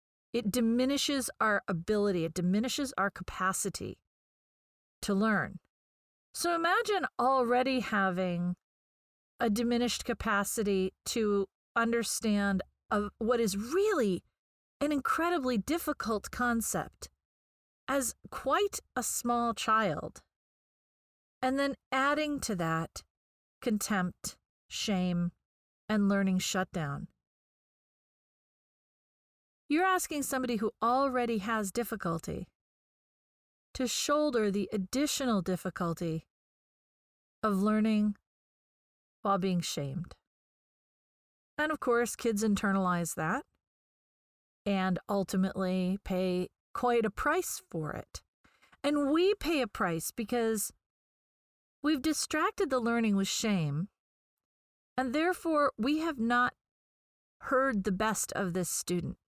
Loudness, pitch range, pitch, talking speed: -31 LUFS, 190-260 Hz, 220 Hz, 95 wpm